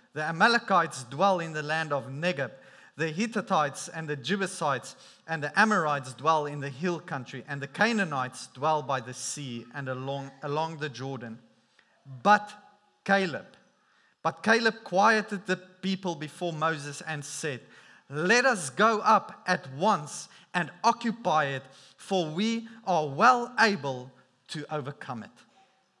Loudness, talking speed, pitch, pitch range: -28 LUFS, 140 wpm, 160 Hz, 140-195 Hz